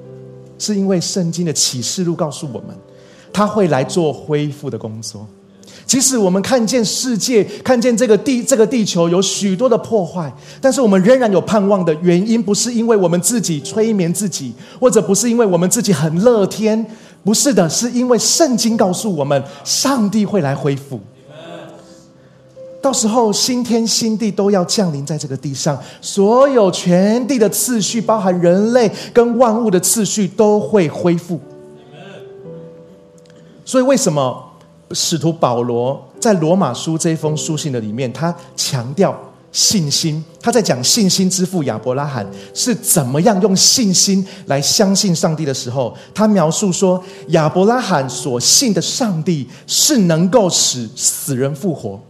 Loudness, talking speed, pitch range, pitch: -15 LUFS, 240 characters per minute, 150-220 Hz, 185 Hz